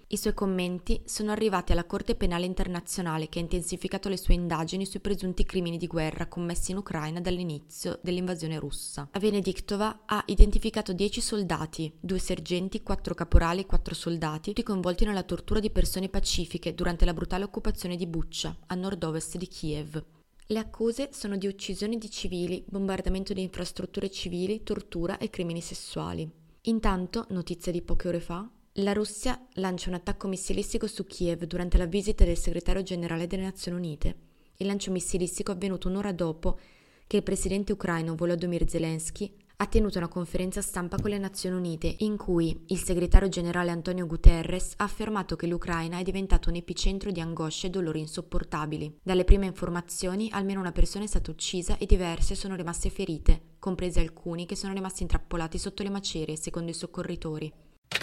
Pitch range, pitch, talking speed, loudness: 170-200 Hz, 180 Hz, 170 wpm, -31 LUFS